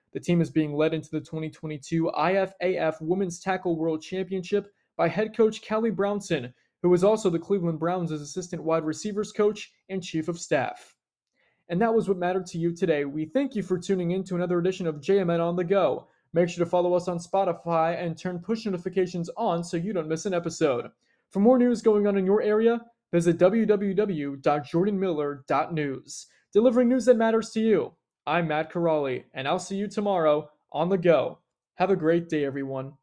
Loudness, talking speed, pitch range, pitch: -26 LUFS, 190 wpm, 160-200 Hz, 180 Hz